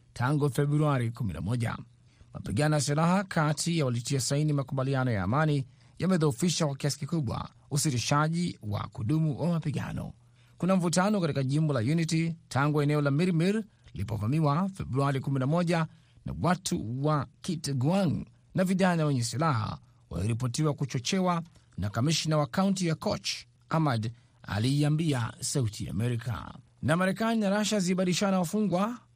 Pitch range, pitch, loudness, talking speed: 125-165 Hz, 150 Hz, -29 LUFS, 125 wpm